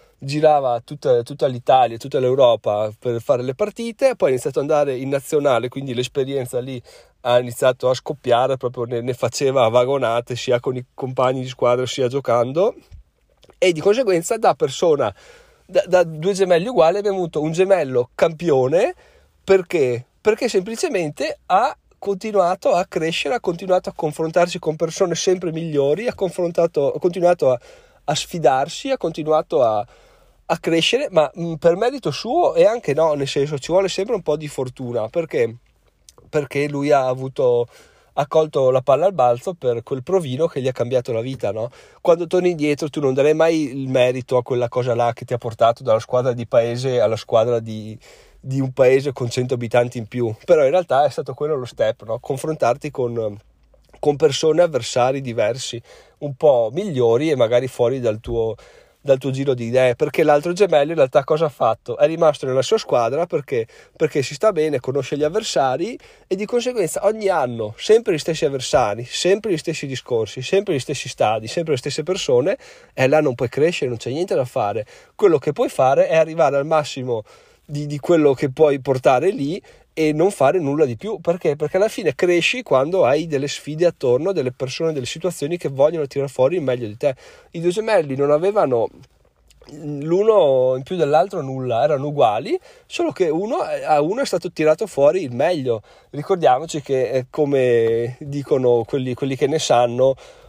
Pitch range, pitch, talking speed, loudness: 125-180 Hz, 145 Hz, 180 wpm, -19 LUFS